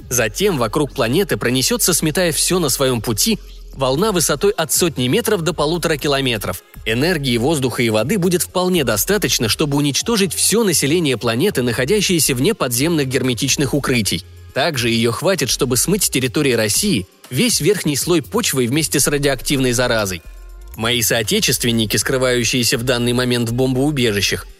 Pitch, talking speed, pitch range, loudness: 135 Hz, 140 wpm, 120-170 Hz, -16 LUFS